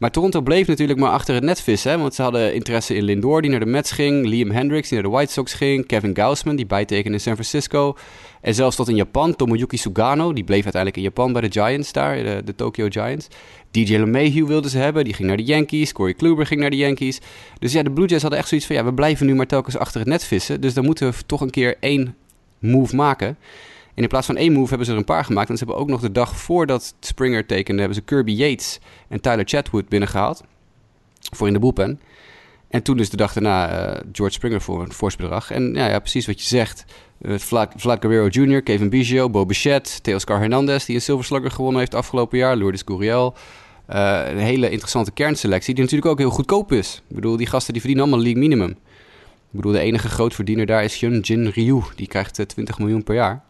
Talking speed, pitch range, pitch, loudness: 235 wpm, 105-140 Hz, 120 Hz, -19 LUFS